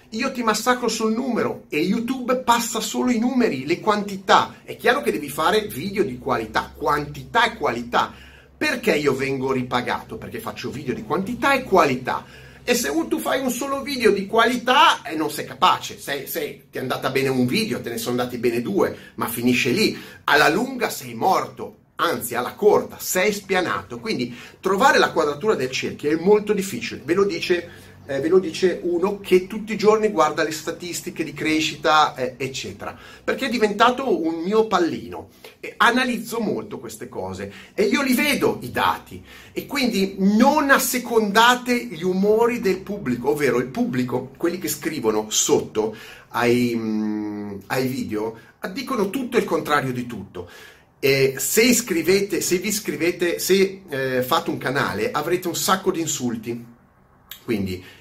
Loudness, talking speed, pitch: -21 LUFS, 165 wpm, 185 Hz